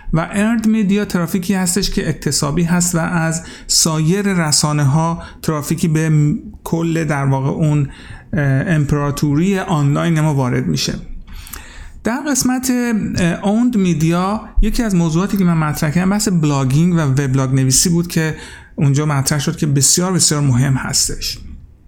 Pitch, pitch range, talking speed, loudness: 165 Hz, 145-185 Hz, 135 wpm, -16 LUFS